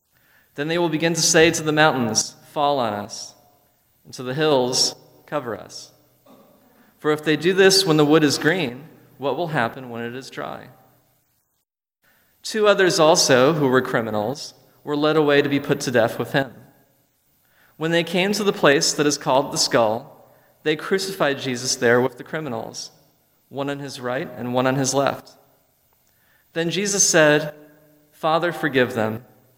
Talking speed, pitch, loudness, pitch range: 170 wpm, 150 Hz, -20 LUFS, 130-165 Hz